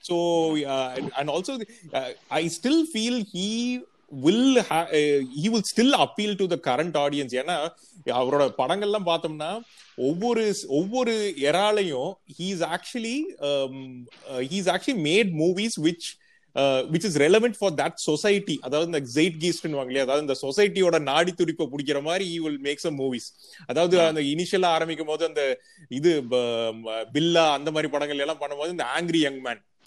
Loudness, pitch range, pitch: -25 LUFS, 145-205 Hz, 165 Hz